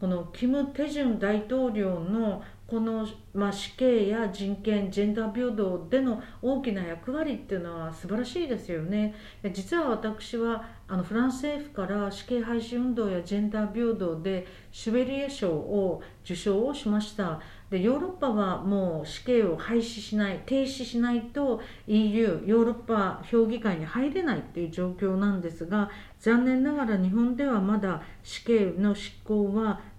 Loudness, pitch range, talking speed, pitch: -28 LUFS, 195-240 Hz, 315 characters per minute, 215 Hz